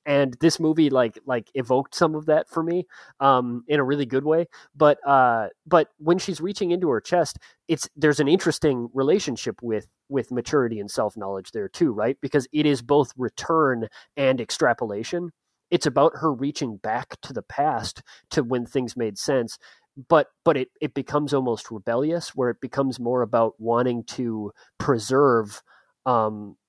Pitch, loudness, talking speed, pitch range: 140 Hz, -23 LUFS, 170 wpm, 120-155 Hz